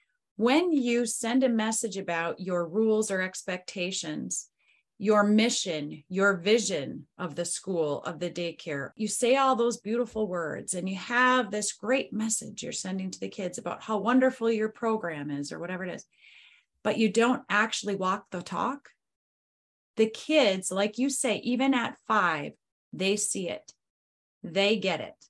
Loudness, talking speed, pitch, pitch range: -28 LUFS, 160 wpm, 210 Hz, 185-235 Hz